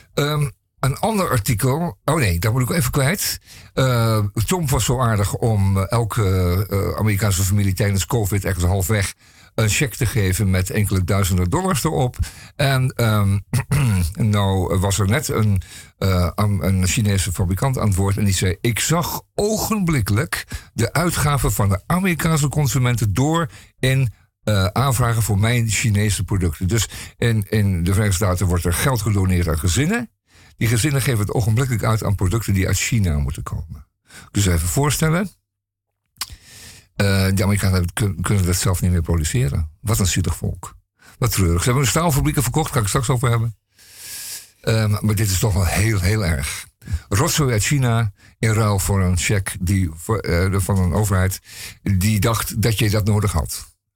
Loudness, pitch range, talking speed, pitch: -19 LUFS, 95-120 Hz, 170 wpm, 105 Hz